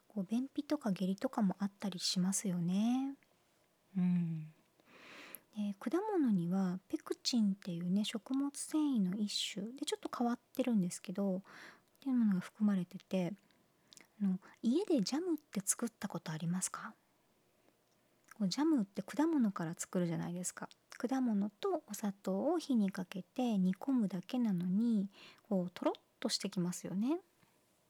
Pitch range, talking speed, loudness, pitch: 185-260 Hz, 270 characters per minute, -37 LUFS, 205 Hz